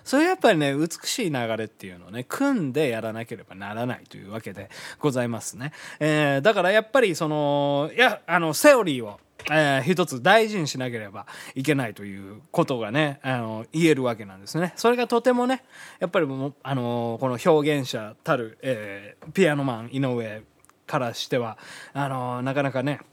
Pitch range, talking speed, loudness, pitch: 115-160 Hz, 370 characters per minute, -24 LUFS, 140 Hz